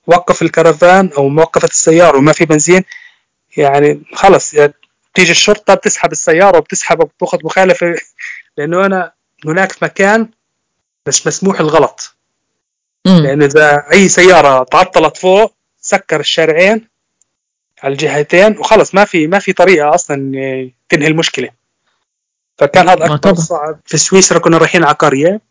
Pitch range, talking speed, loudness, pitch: 155-190 Hz, 130 wpm, -9 LUFS, 170 Hz